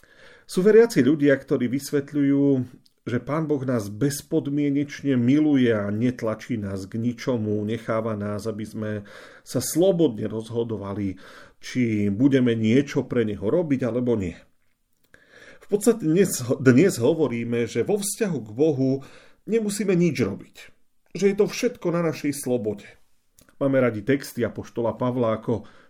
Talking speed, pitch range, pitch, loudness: 135 wpm, 115-145 Hz, 130 Hz, -23 LUFS